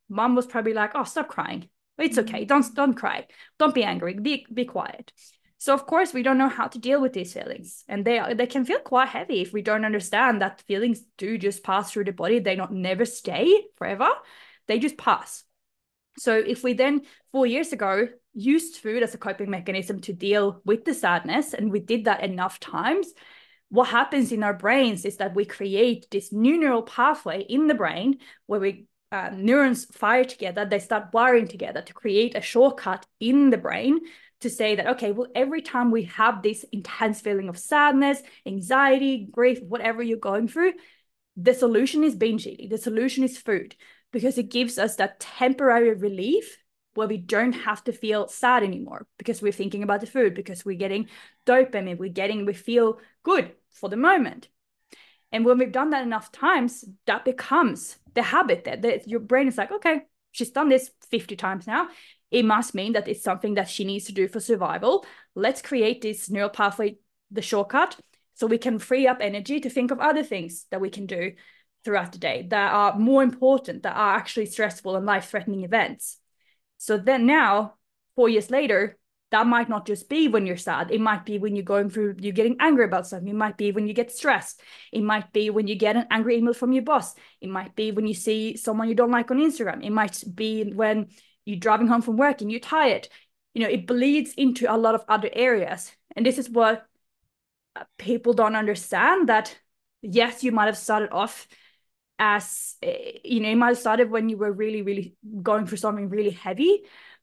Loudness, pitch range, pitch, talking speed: -24 LUFS, 205-260 Hz, 225 Hz, 200 wpm